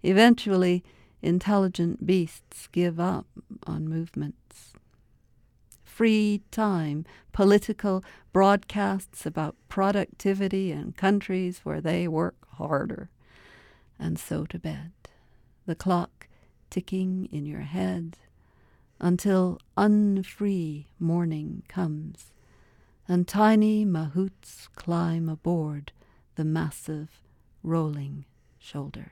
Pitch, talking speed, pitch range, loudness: 175 Hz, 85 wpm, 155-195 Hz, -27 LUFS